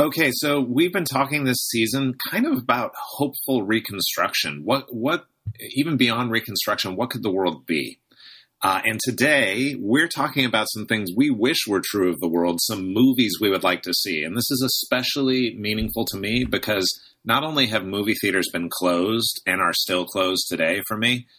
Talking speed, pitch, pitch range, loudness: 185 wpm, 115 Hz, 105-135 Hz, -22 LUFS